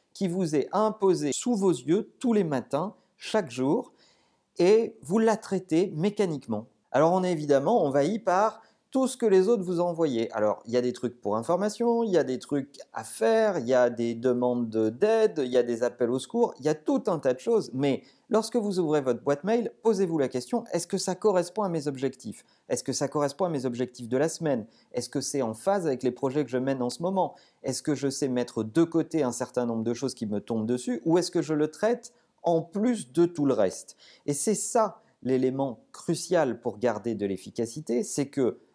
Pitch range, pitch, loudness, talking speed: 125-200 Hz, 155 Hz, -27 LUFS, 225 wpm